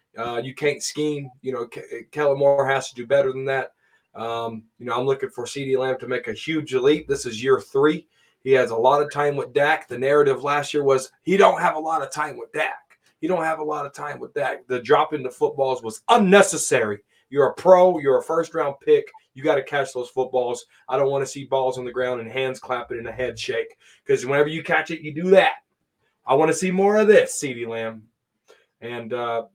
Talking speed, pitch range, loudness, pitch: 240 wpm, 125-180 Hz, -21 LUFS, 140 Hz